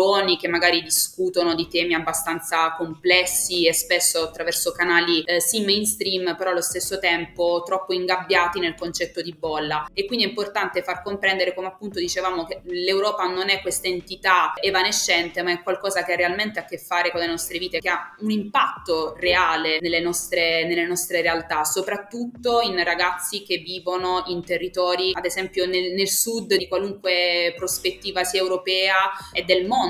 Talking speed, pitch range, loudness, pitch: 165 wpm, 170-190 Hz, -22 LUFS, 180 Hz